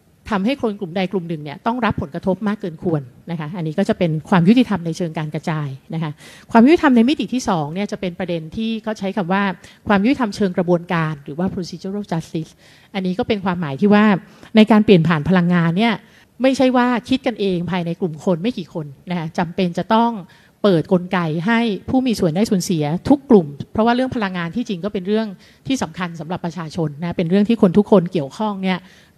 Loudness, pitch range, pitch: -19 LUFS, 175-215 Hz, 190 Hz